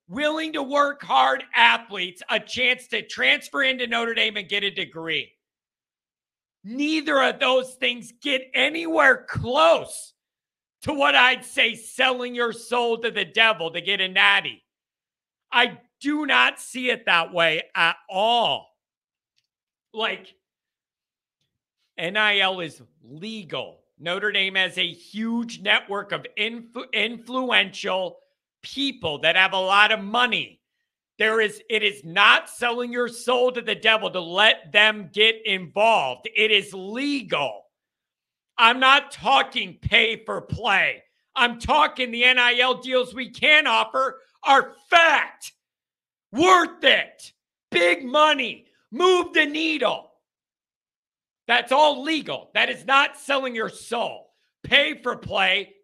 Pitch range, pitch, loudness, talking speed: 205-265 Hz, 235 Hz, -20 LUFS, 130 wpm